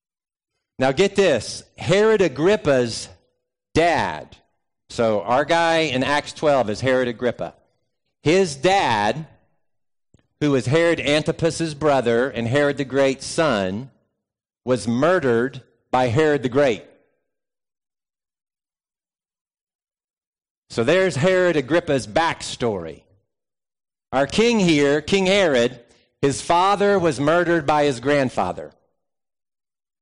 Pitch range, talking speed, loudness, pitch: 125-170 Hz, 100 wpm, -20 LUFS, 145 Hz